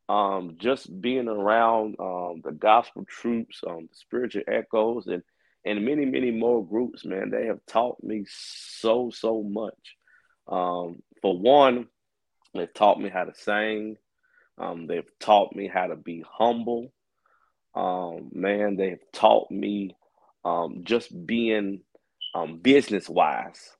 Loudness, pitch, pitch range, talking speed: -25 LUFS, 105 Hz, 95-115 Hz, 140 wpm